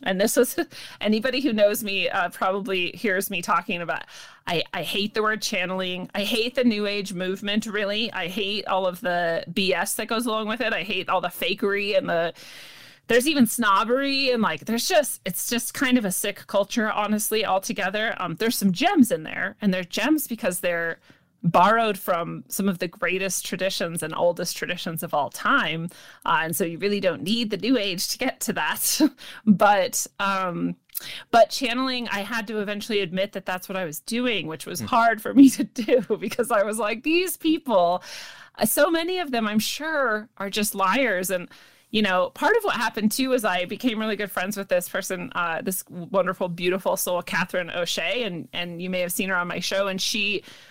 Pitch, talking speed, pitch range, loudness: 205 Hz, 200 wpm, 185-230 Hz, -24 LUFS